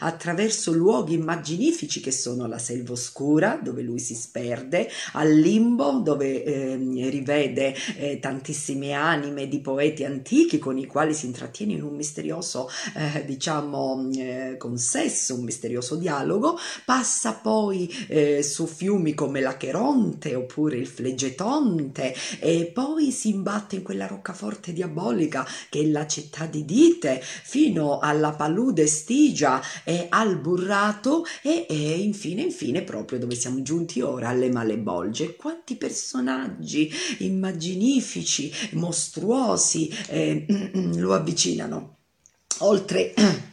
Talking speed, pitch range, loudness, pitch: 120 wpm, 135-205 Hz, -24 LUFS, 155 Hz